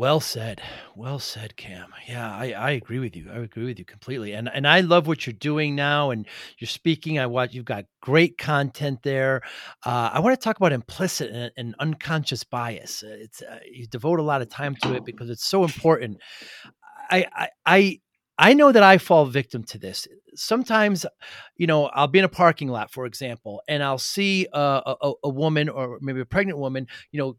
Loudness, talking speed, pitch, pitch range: -22 LUFS, 210 wpm, 135 Hz, 120-160 Hz